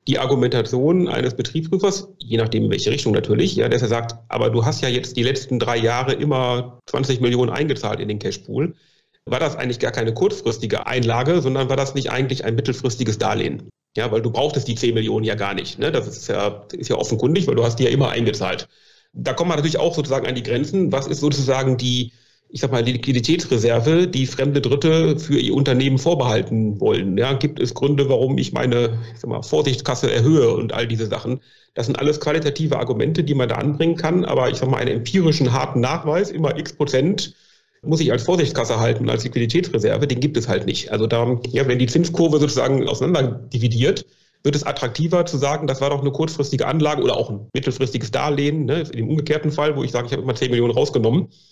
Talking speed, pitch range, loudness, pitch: 210 wpm, 120-150 Hz, -20 LUFS, 135 Hz